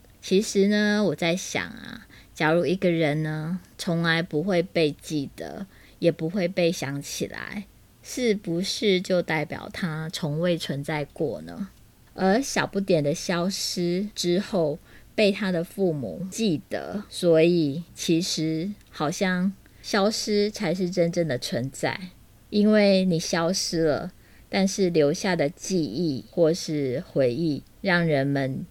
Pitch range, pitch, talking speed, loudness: 155-195 Hz, 170 Hz, 190 characters per minute, -25 LUFS